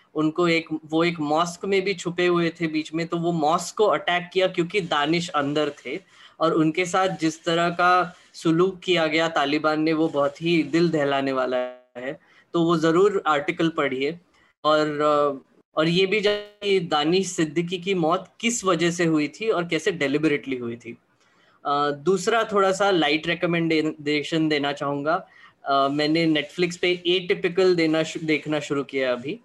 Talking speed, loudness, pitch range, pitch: 165 wpm, -23 LUFS, 150-180 Hz, 165 Hz